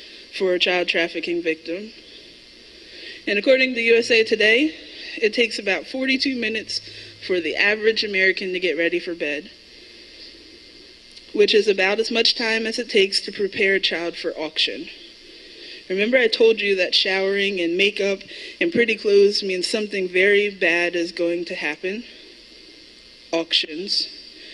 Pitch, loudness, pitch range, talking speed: 205 Hz, -20 LUFS, 180-245 Hz, 145 wpm